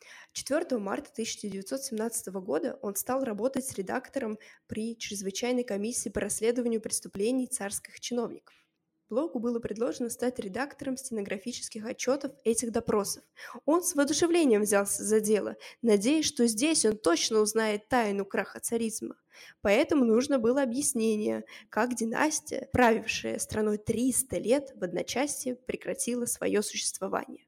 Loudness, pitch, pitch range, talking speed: -29 LUFS, 235 Hz, 215-260 Hz, 120 wpm